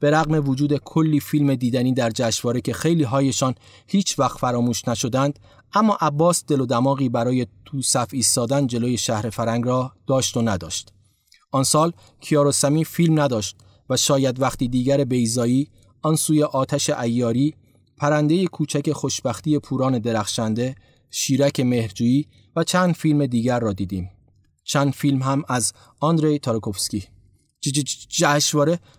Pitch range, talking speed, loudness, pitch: 115-145 Hz, 135 wpm, -21 LUFS, 130 Hz